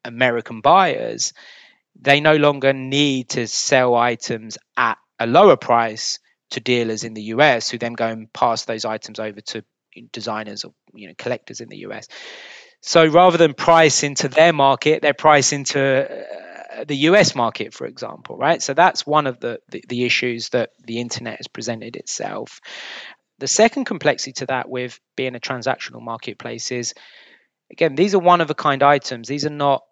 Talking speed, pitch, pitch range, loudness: 175 wpm, 135 Hz, 120-150 Hz, -18 LUFS